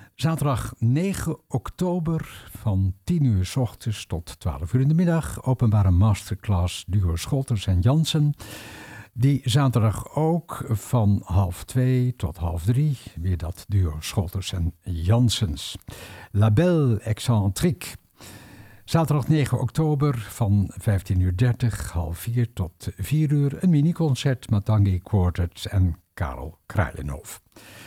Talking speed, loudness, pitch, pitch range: 125 wpm, -24 LUFS, 110 Hz, 95-130 Hz